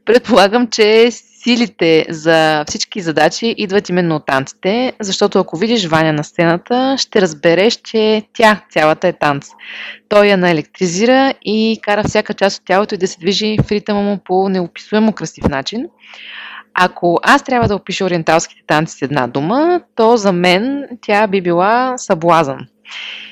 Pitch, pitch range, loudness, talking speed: 200 Hz, 170-225 Hz, -14 LUFS, 155 wpm